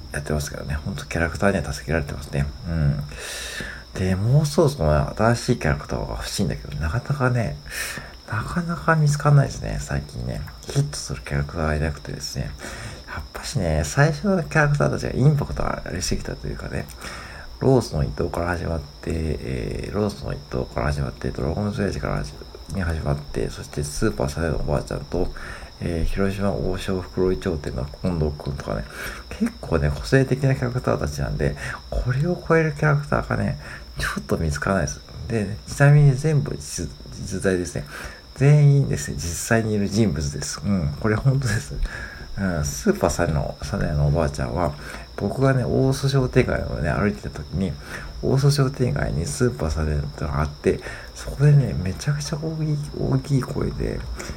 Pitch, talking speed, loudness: 85 Hz, 380 characters per minute, -23 LUFS